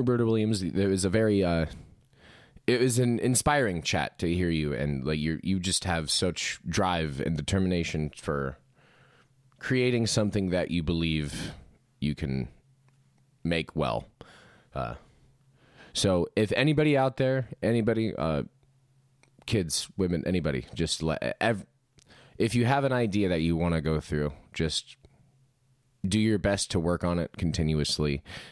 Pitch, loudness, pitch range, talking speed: 95 Hz, -28 LUFS, 80-125 Hz, 145 wpm